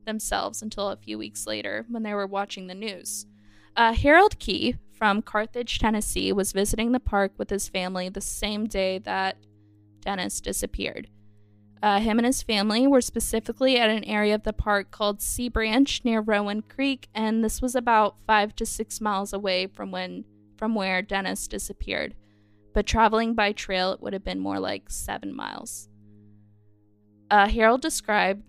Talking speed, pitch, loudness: 170 wpm, 205 Hz, -25 LUFS